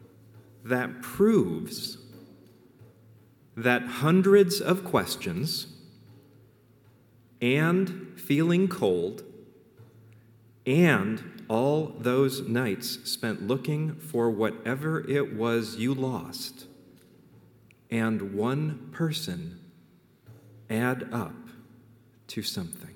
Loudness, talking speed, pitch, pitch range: -27 LUFS, 75 wpm, 125 Hz, 115-150 Hz